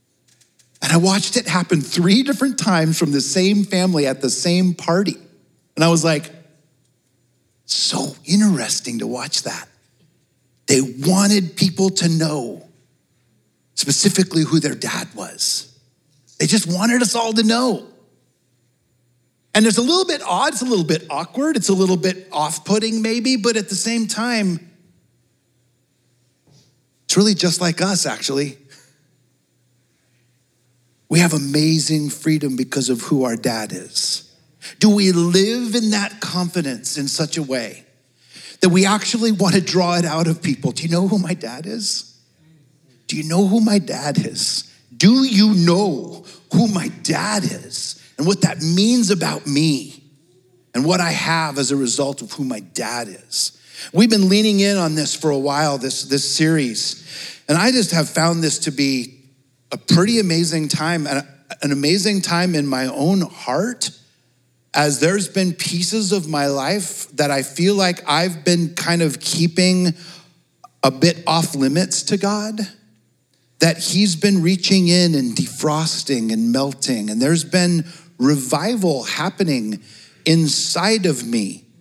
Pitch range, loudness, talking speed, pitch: 140-190 Hz, -18 LUFS, 155 wpm, 165 Hz